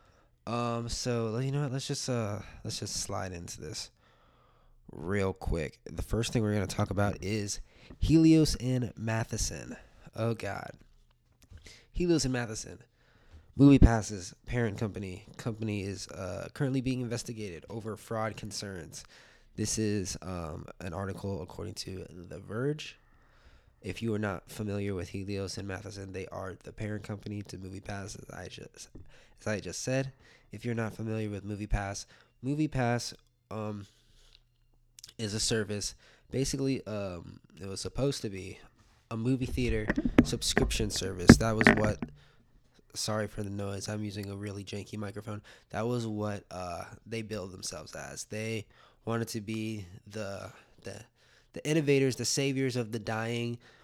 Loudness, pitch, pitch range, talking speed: -32 LUFS, 110 Hz, 100-120 Hz, 150 wpm